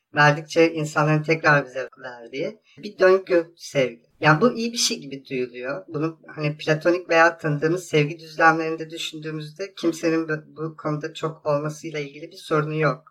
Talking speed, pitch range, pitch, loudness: 145 wpm, 150-165 Hz, 155 Hz, -22 LUFS